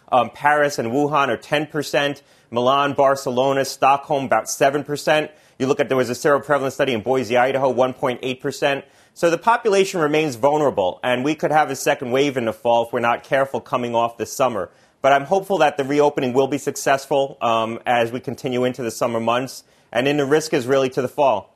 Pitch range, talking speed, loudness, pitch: 125-145 Hz, 200 wpm, -20 LUFS, 135 Hz